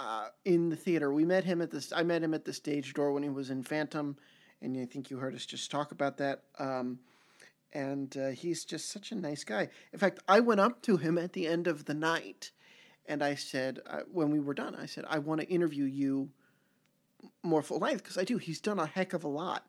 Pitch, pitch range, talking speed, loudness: 150 Hz, 140-170 Hz, 245 wpm, -33 LUFS